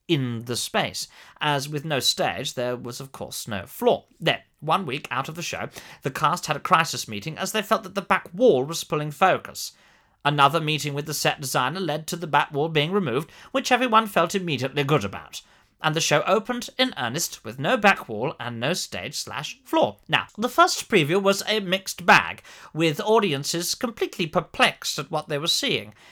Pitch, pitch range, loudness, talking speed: 165 Hz, 145-200 Hz, -23 LUFS, 200 wpm